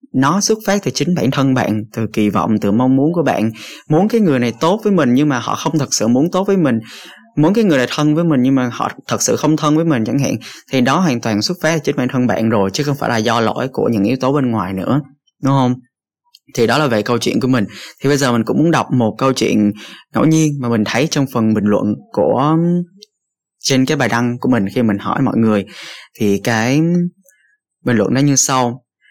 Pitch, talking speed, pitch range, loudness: 135 Hz, 255 wpm, 115-160 Hz, -15 LUFS